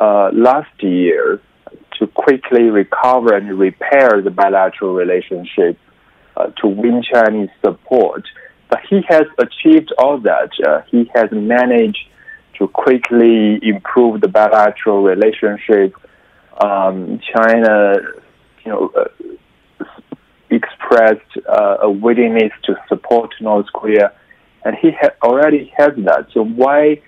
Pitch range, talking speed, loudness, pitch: 105-145 Hz, 115 wpm, -13 LUFS, 115 Hz